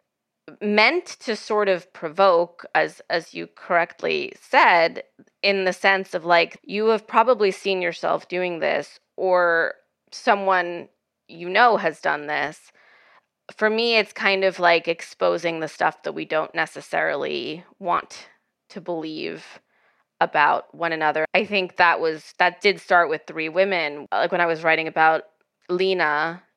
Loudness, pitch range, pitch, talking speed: -21 LUFS, 170-205 Hz, 180 Hz, 145 wpm